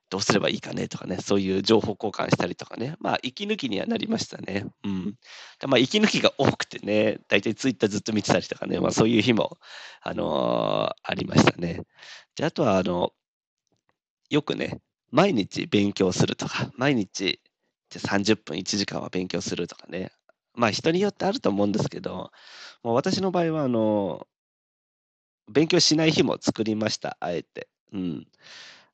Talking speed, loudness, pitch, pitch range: 335 characters per minute, -25 LUFS, 110 Hz, 100-165 Hz